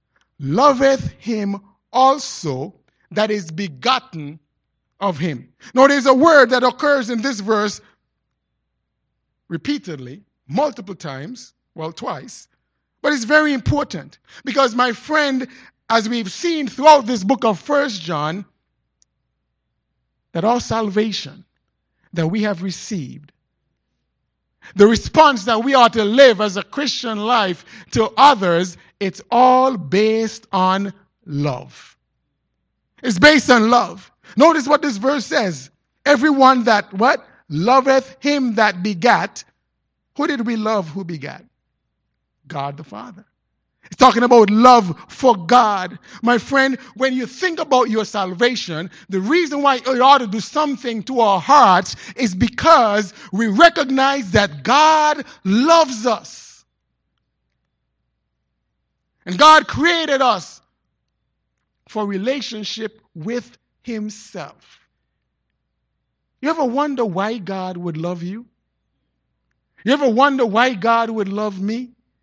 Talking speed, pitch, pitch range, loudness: 120 wpm, 225 Hz, 185-265 Hz, -16 LUFS